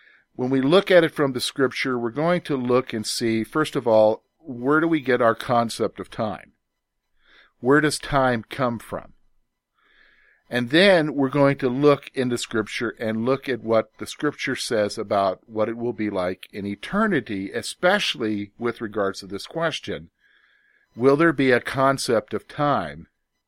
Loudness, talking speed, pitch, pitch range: -22 LUFS, 170 wpm, 125 Hz, 110-145 Hz